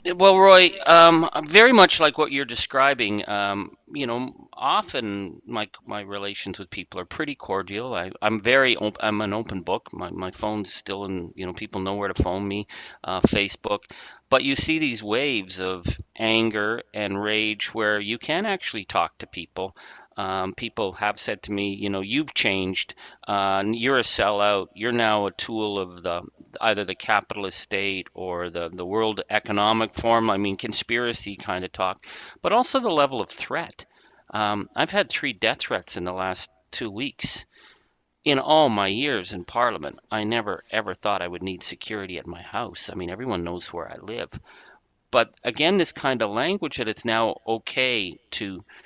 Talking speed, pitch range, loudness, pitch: 180 wpm, 95-115 Hz, -23 LUFS, 105 Hz